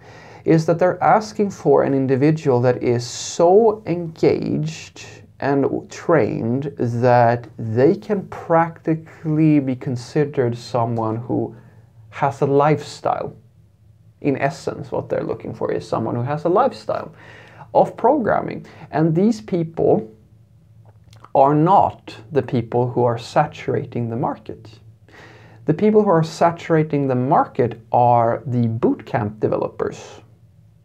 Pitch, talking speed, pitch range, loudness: 130 Hz, 120 wpm, 115-155 Hz, -19 LUFS